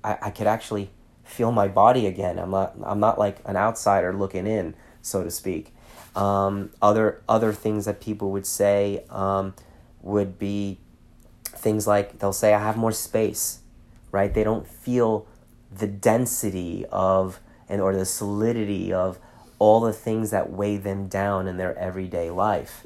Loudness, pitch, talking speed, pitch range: -24 LUFS, 100 Hz, 160 wpm, 95-110 Hz